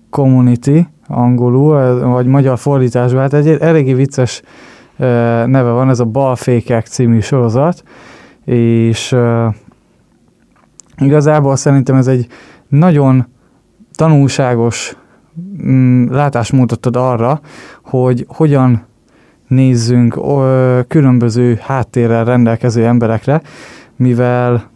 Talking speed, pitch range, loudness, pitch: 80 wpm, 120-140 Hz, -11 LUFS, 125 Hz